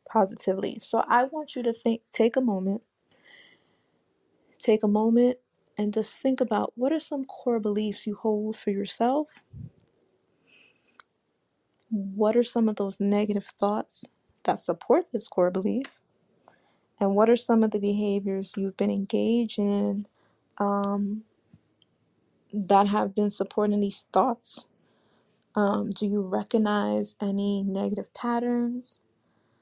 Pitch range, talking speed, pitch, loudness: 200-235 Hz, 130 wpm, 210 Hz, -27 LUFS